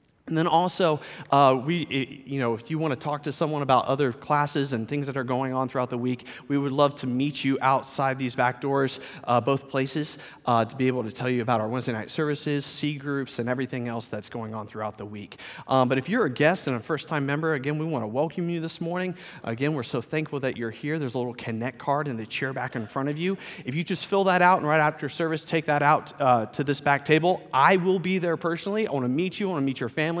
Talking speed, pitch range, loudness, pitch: 270 wpm, 125-155 Hz, -26 LUFS, 140 Hz